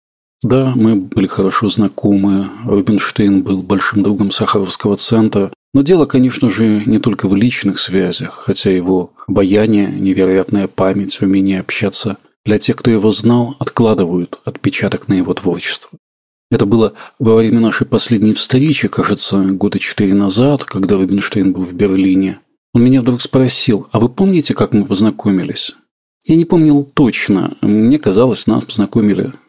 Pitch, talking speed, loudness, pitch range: 100 Hz, 145 wpm, -13 LUFS, 95-120 Hz